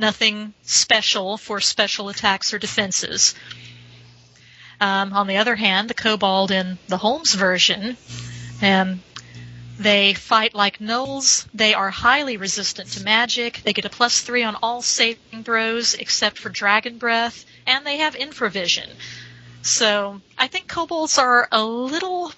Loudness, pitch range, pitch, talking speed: -19 LUFS, 195-235 Hz, 215 Hz, 140 wpm